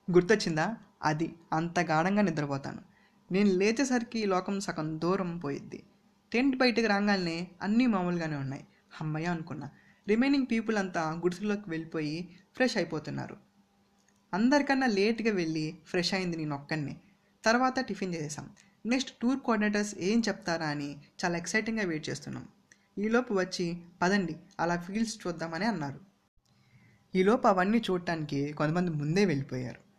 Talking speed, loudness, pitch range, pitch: 120 wpm, -30 LUFS, 165-210 Hz, 185 Hz